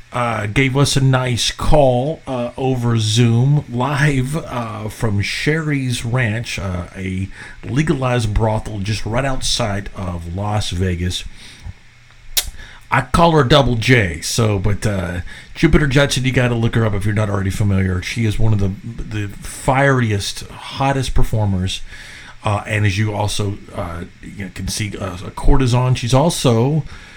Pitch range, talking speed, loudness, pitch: 100-130 Hz, 145 wpm, -18 LUFS, 115 Hz